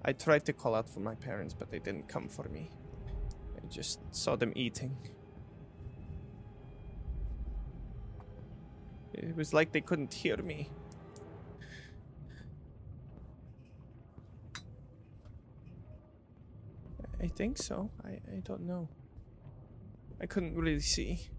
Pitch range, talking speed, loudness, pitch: 100-135 Hz, 105 wpm, -37 LUFS, 115 Hz